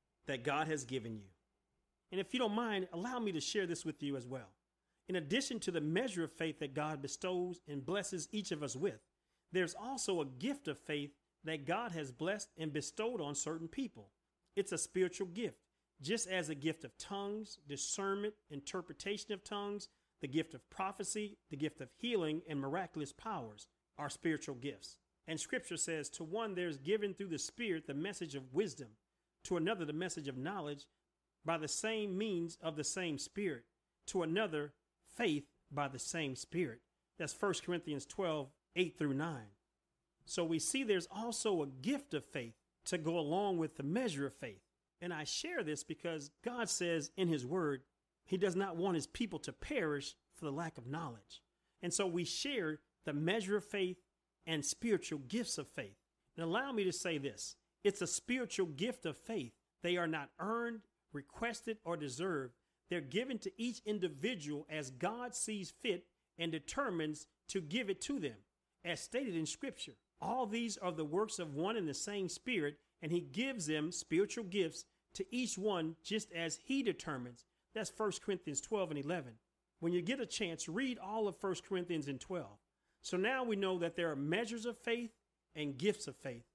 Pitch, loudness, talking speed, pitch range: 175 Hz, -40 LUFS, 185 wpm, 150-205 Hz